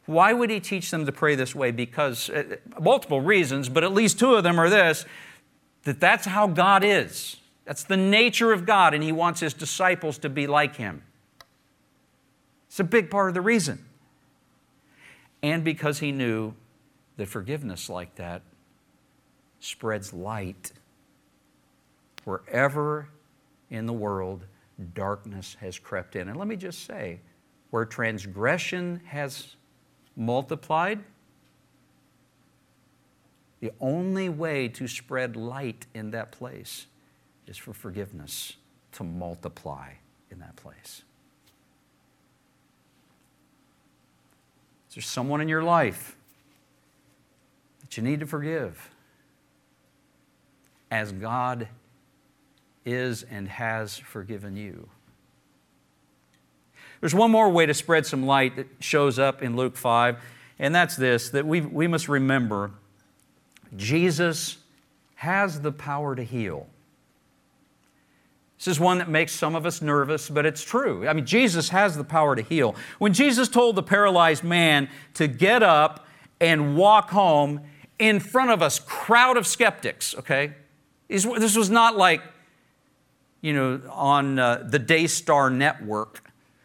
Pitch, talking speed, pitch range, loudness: 145 Hz, 130 wpm, 115-170 Hz, -23 LUFS